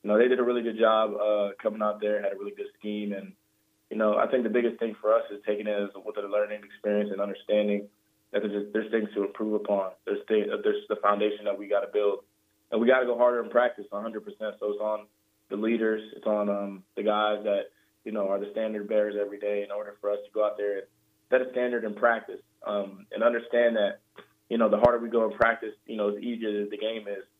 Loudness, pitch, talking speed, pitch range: -28 LUFS, 105 Hz, 255 wpm, 105-115 Hz